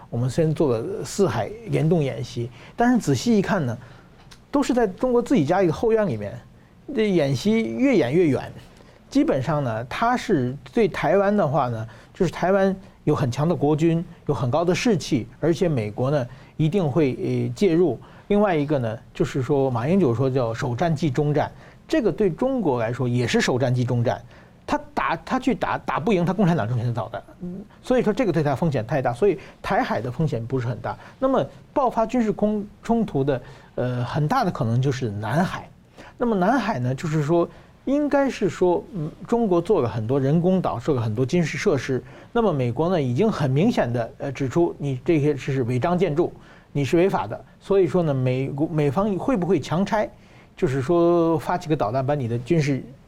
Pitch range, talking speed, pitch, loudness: 130-195 Hz, 285 characters per minute, 155 Hz, -23 LUFS